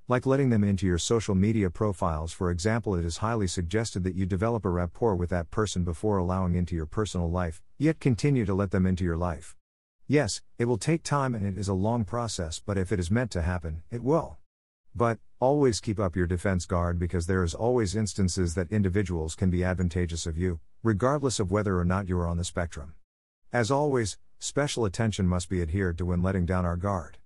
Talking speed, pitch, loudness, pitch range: 215 wpm, 95 Hz, -28 LUFS, 90-110 Hz